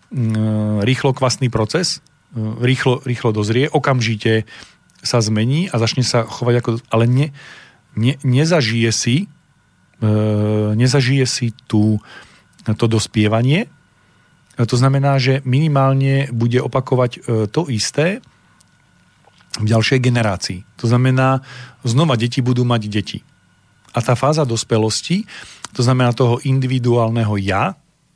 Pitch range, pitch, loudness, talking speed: 110-135 Hz, 125 Hz, -17 LUFS, 110 wpm